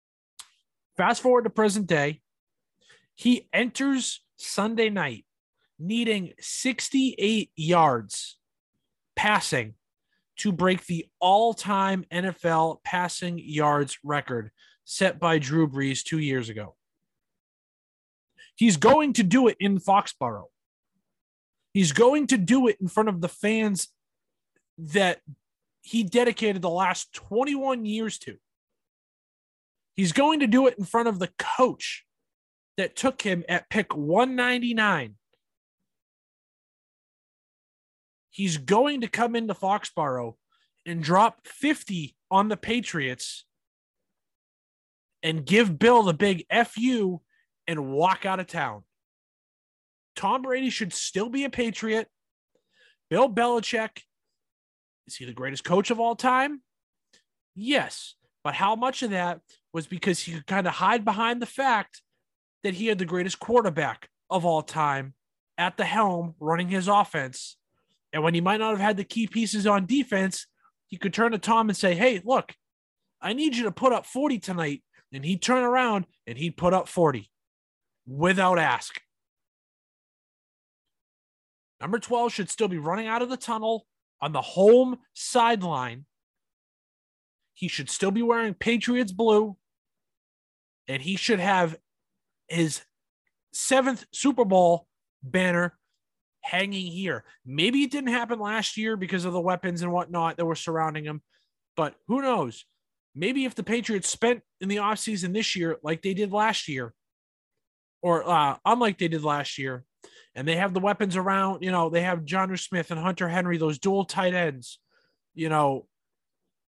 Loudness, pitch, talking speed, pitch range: -25 LUFS, 195 Hz, 140 wpm, 165-230 Hz